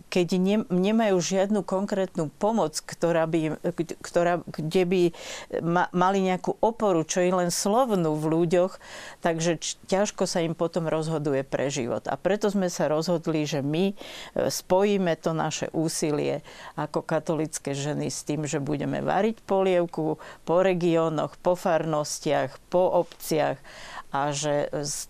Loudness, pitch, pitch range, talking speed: -26 LUFS, 175 Hz, 155-185 Hz, 135 wpm